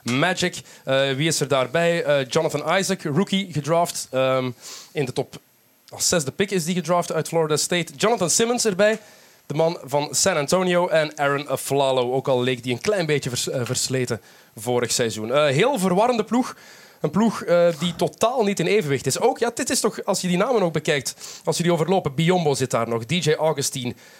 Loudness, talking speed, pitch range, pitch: -22 LUFS, 200 wpm, 135-185 Hz, 160 Hz